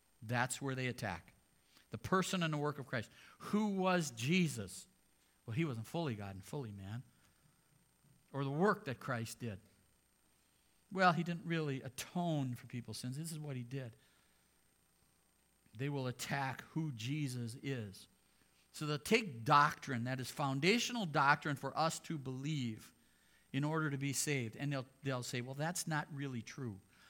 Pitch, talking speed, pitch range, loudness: 135 Hz, 160 wpm, 120-155 Hz, -38 LUFS